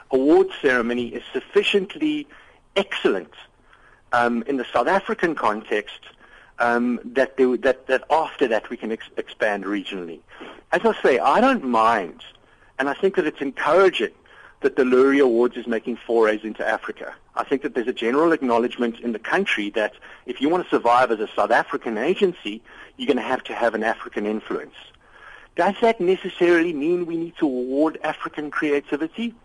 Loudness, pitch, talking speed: -21 LUFS, 140 Hz, 175 wpm